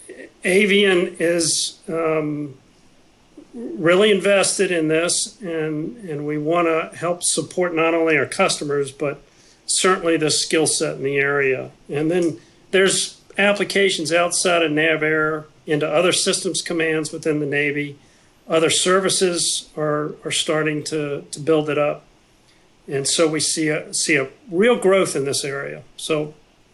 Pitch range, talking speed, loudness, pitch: 150-180 Hz, 140 wpm, -19 LUFS, 160 Hz